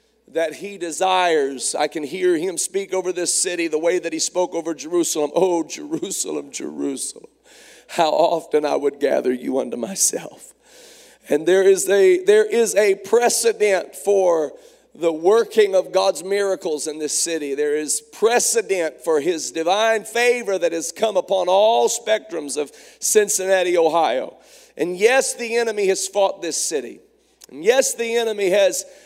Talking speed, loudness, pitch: 155 wpm, -19 LUFS, 205 Hz